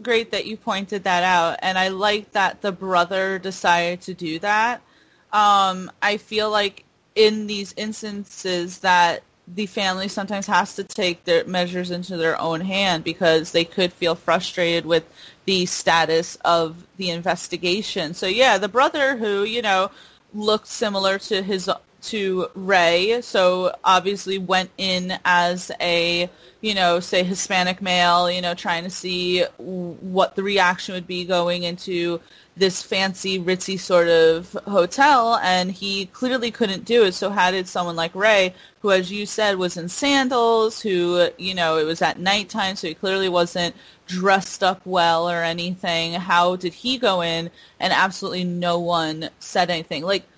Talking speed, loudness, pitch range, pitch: 160 wpm, -20 LUFS, 175-200 Hz, 185 Hz